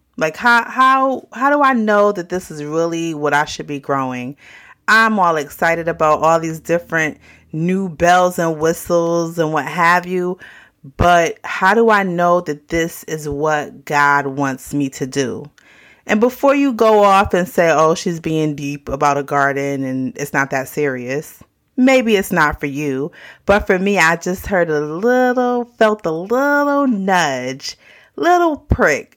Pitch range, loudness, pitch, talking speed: 145-205 Hz, -16 LUFS, 165 Hz, 170 wpm